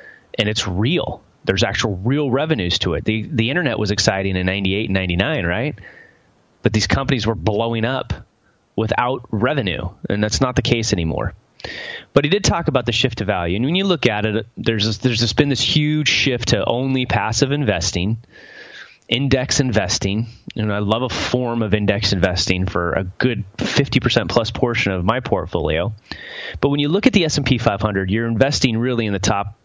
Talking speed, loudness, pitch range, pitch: 190 wpm, -19 LUFS, 100-130 Hz, 115 Hz